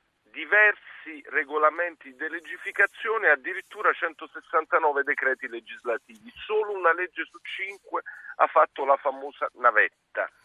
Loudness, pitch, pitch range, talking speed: -25 LUFS, 160 Hz, 150-210 Hz, 110 wpm